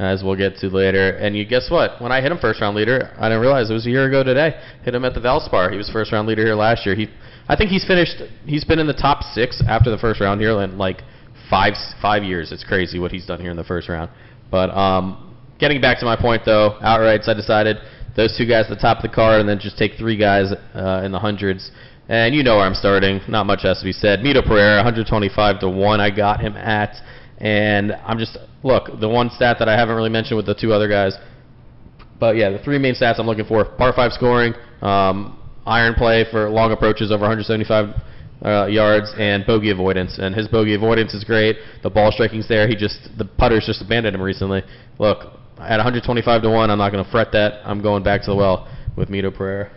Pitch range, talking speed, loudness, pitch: 100-115 Hz, 240 wpm, -18 LUFS, 110 Hz